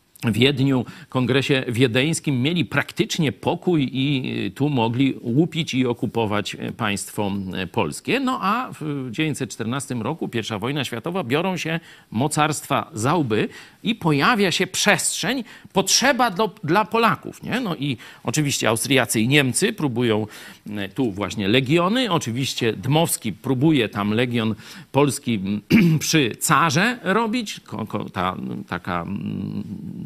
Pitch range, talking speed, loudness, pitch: 115-170 Hz, 115 wpm, -21 LUFS, 140 Hz